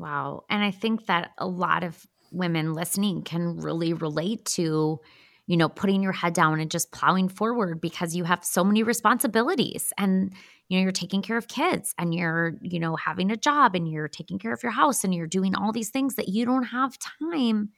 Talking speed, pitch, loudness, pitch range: 215 wpm, 190 Hz, -25 LUFS, 170-220 Hz